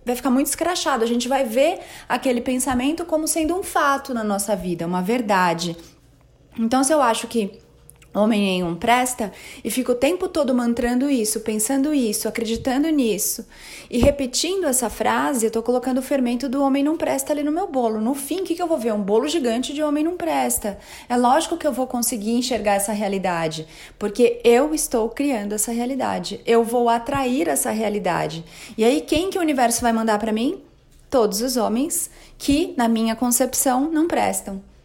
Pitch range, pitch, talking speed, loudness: 220-280 Hz, 245 Hz, 185 wpm, -21 LUFS